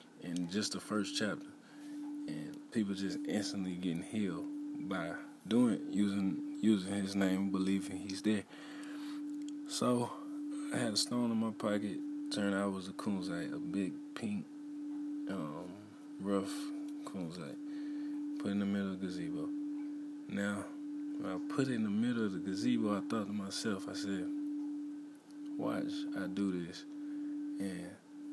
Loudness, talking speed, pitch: -38 LUFS, 150 wpm, 150 Hz